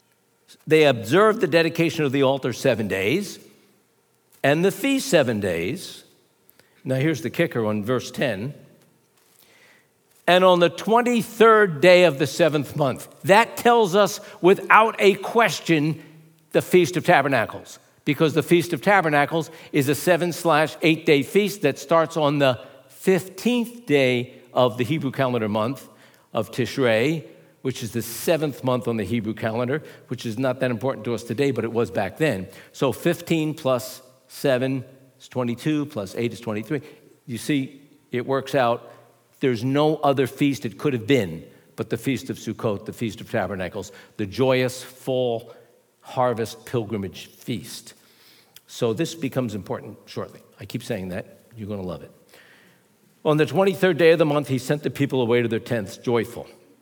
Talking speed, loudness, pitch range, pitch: 165 wpm, -22 LUFS, 120-165 Hz, 140 Hz